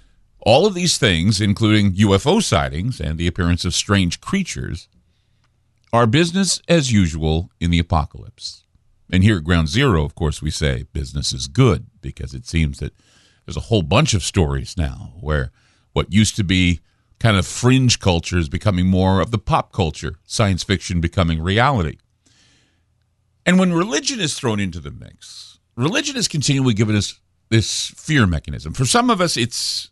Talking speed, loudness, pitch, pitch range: 170 wpm, -18 LUFS, 100 Hz, 85-115 Hz